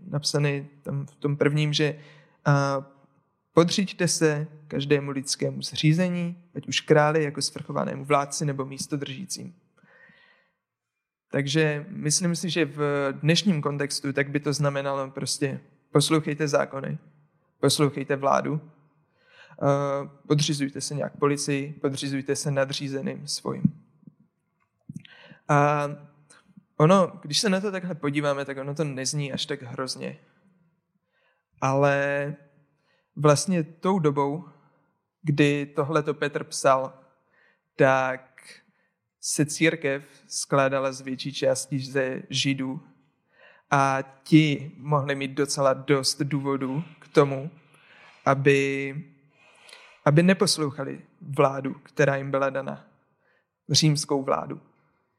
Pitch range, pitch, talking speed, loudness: 140-155 Hz, 145 Hz, 100 wpm, -25 LUFS